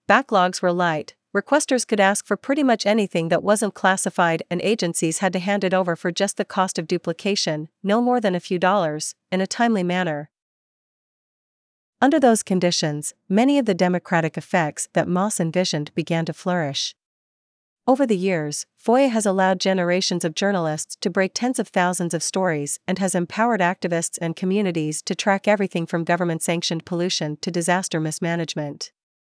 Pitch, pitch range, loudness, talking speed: 185 Hz, 170-200 Hz, -21 LUFS, 170 wpm